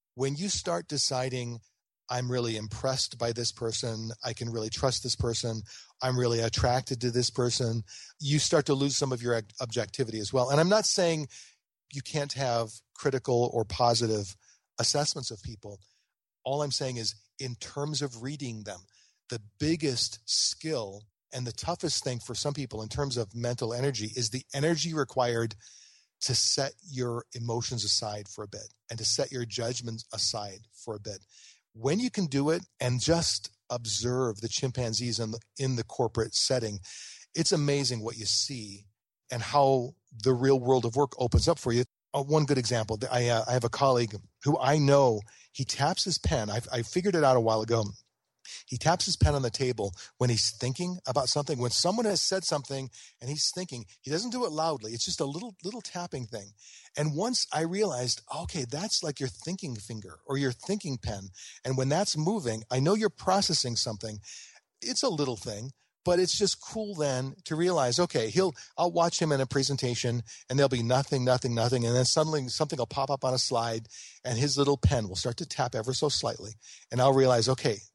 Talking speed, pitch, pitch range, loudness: 195 wpm, 125 Hz, 115-145 Hz, -29 LUFS